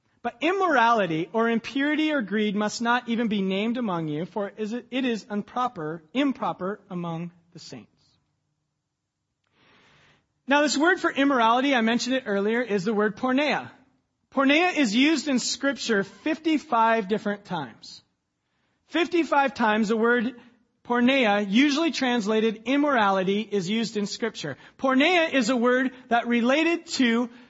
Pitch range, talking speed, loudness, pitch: 205-270 Hz, 135 wpm, -24 LUFS, 235 Hz